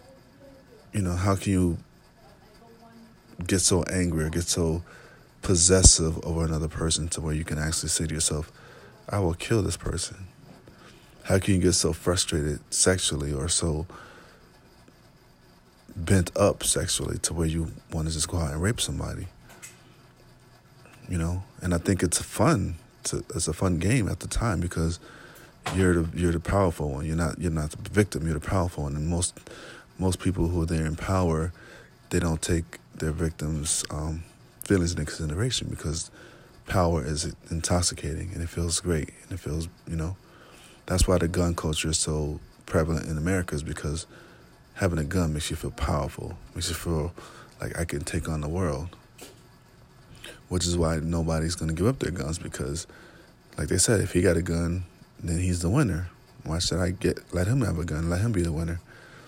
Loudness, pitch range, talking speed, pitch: -26 LUFS, 80-95 Hz, 180 wpm, 85 Hz